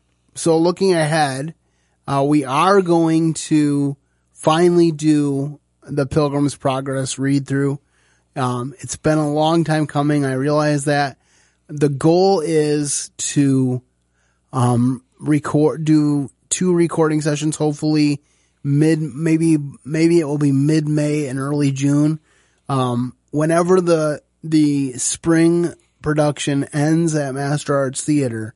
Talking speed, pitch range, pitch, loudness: 120 wpm, 135-155 Hz, 150 Hz, -18 LUFS